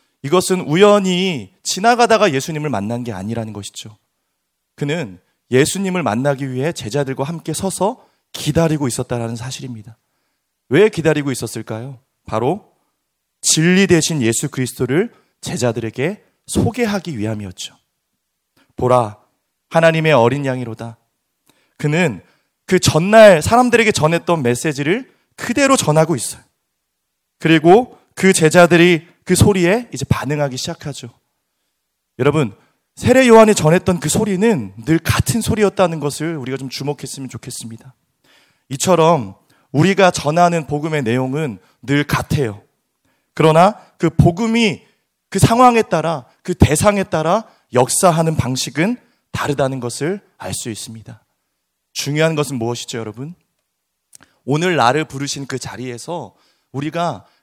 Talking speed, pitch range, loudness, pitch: 290 characters per minute, 120-175 Hz, -16 LUFS, 145 Hz